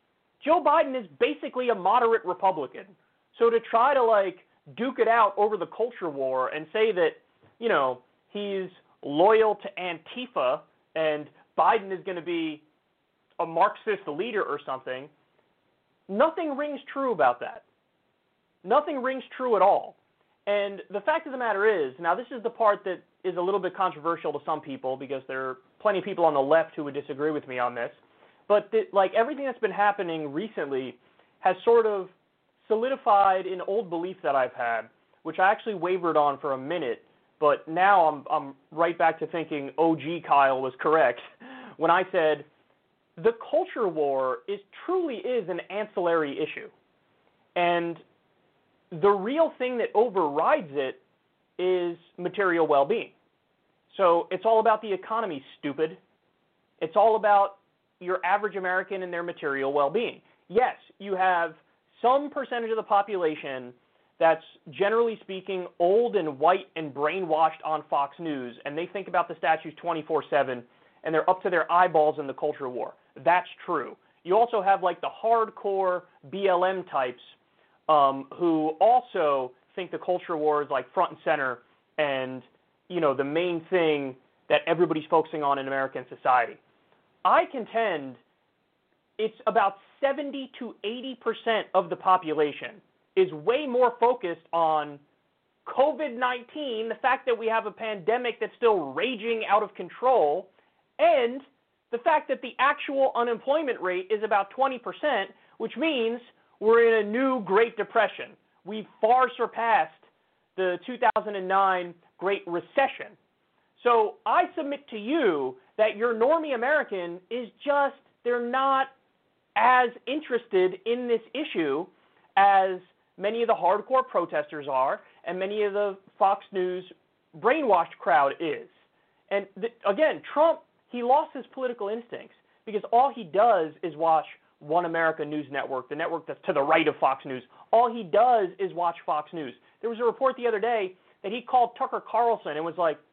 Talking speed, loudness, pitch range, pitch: 160 wpm, -26 LUFS, 165-240 Hz, 195 Hz